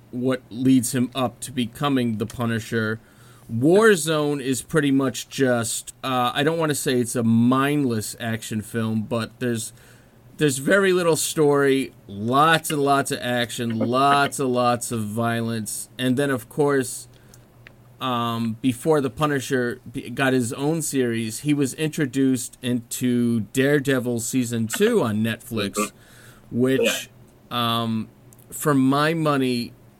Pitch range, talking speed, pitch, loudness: 115-140 Hz, 130 wpm, 125 Hz, -22 LUFS